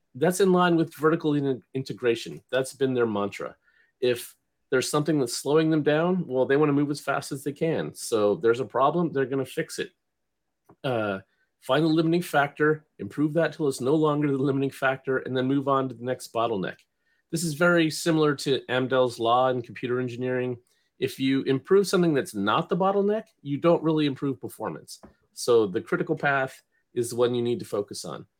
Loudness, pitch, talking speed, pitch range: -25 LUFS, 140 Hz, 200 wpm, 130-160 Hz